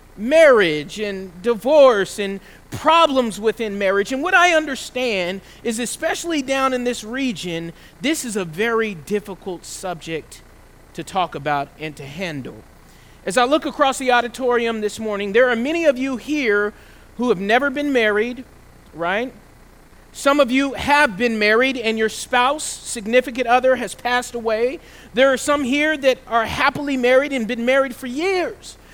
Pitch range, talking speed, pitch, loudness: 205-270 Hz, 160 wpm, 245 Hz, -19 LUFS